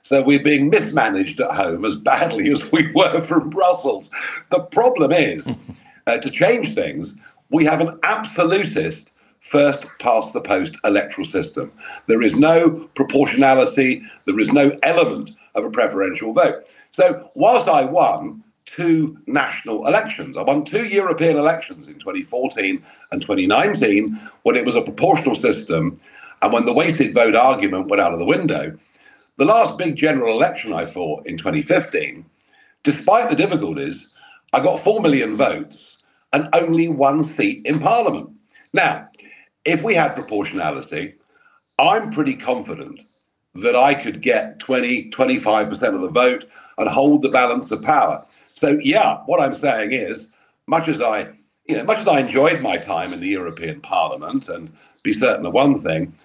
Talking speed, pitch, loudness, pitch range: 160 wpm, 165 Hz, -18 LUFS, 140-240 Hz